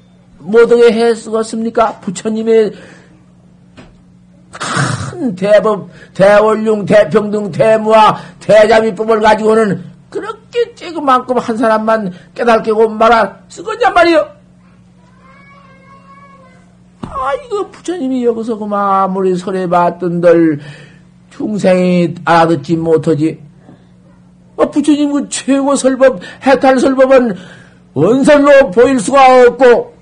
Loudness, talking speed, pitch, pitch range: -11 LUFS, 220 characters per minute, 215 Hz, 170-245 Hz